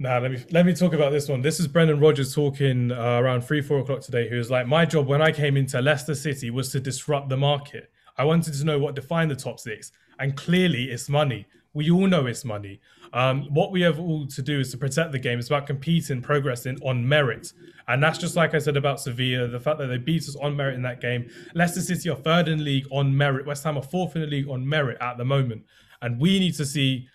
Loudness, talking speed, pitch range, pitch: -24 LUFS, 255 wpm, 130-155 Hz, 140 Hz